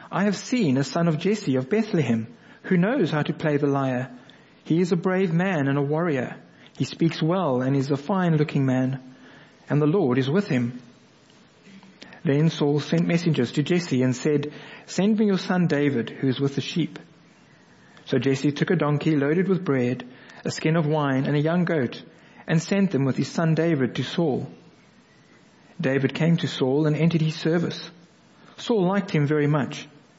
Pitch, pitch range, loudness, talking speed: 155 Hz, 135-175 Hz, -23 LUFS, 190 wpm